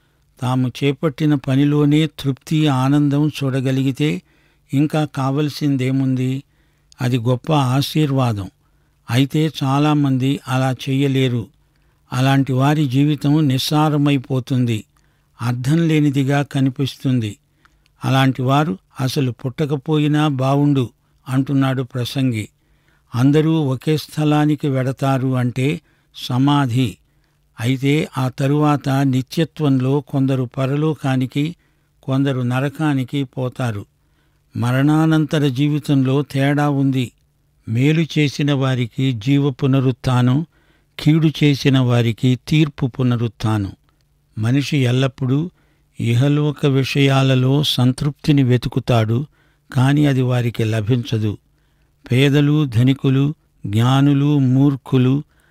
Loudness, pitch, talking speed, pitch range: -18 LUFS, 135 Hz, 75 wpm, 130-150 Hz